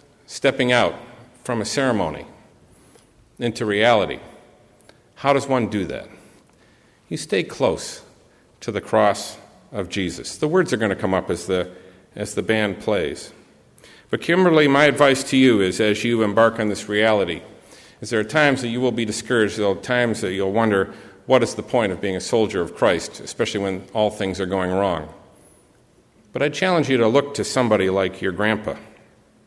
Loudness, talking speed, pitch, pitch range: -20 LUFS, 180 wpm, 110 Hz, 100-125 Hz